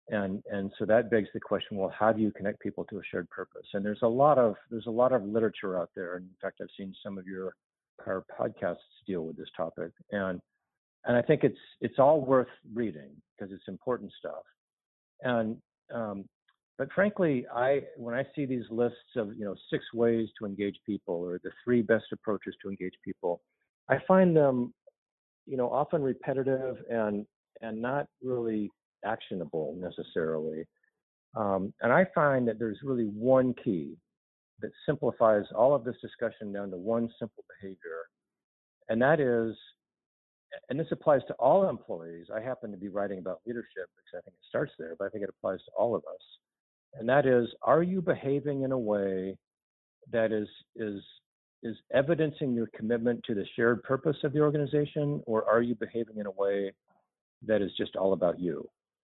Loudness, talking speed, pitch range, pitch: -30 LUFS, 185 wpm, 100-130 Hz, 115 Hz